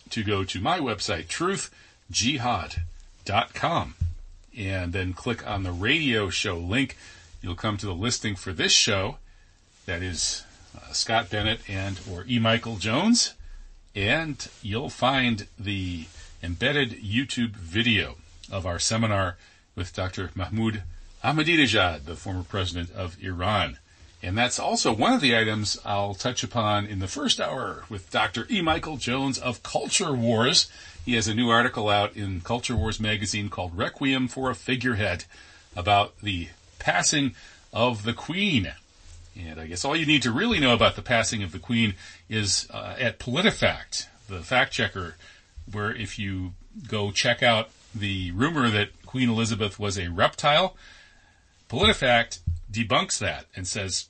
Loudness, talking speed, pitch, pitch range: -25 LUFS, 150 wpm, 105 Hz, 90-120 Hz